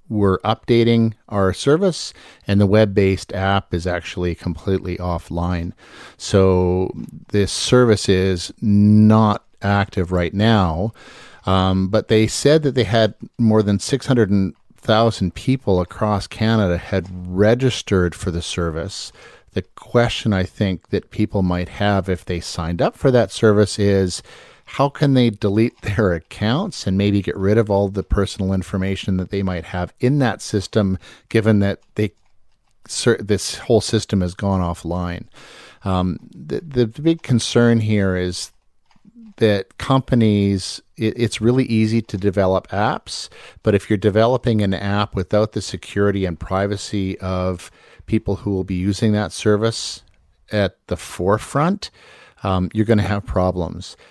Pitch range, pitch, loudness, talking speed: 95-110 Hz, 100 Hz, -19 LUFS, 145 wpm